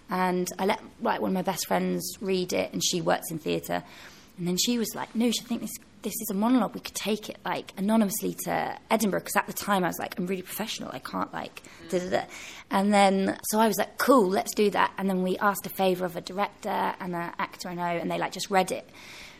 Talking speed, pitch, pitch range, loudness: 250 wpm, 195 Hz, 185-220 Hz, -28 LUFS